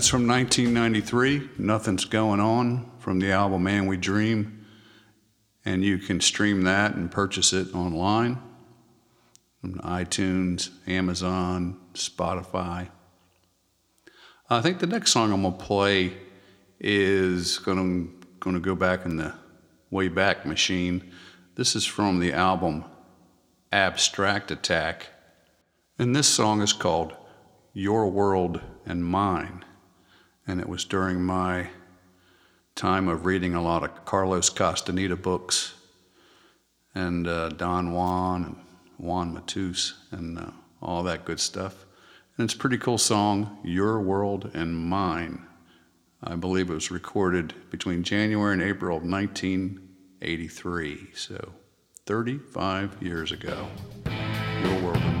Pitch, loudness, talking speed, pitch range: 95 Hz, -26 LUFS, 125 wpm, 90-105 Hz